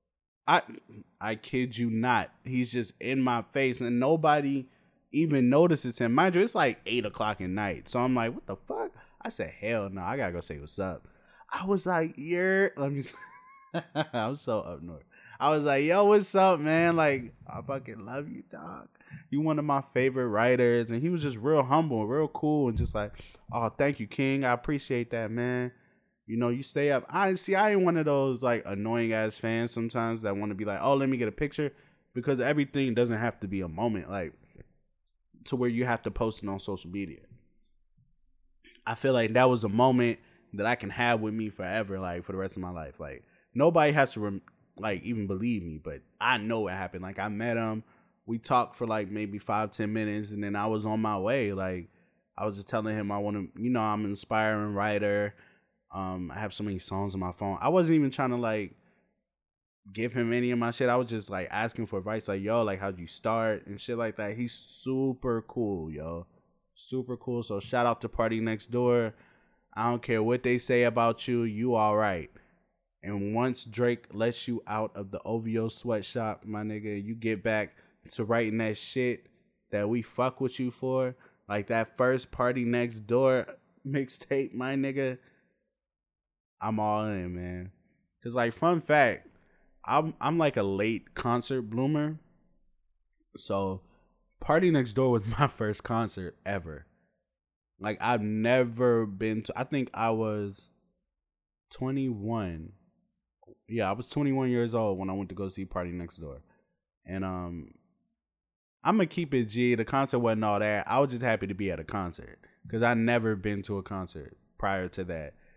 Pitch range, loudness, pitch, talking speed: 105-130 Hz, -29 LUFS, 115 Hz, 195 wpm